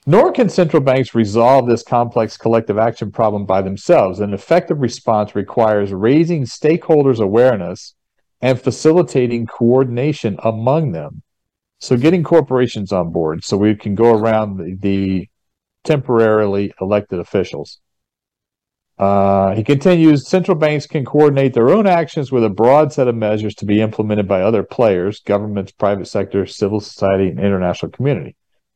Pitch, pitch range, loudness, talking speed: 115 Hz, 100-140 Hz, -15 LUFS, 145 wpm